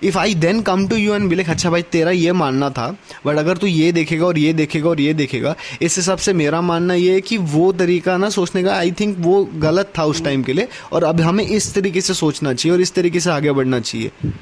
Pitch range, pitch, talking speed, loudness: 155-190 Hz, 175 Hz, 260 wpm, -17 LUFS